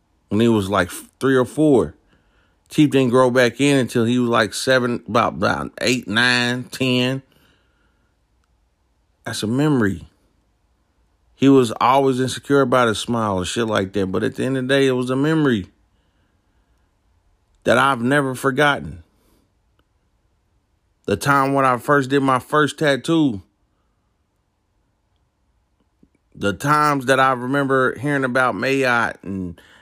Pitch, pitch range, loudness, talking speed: 115 Hz, 95-135 Hz, -18 LUFS, 140 wpm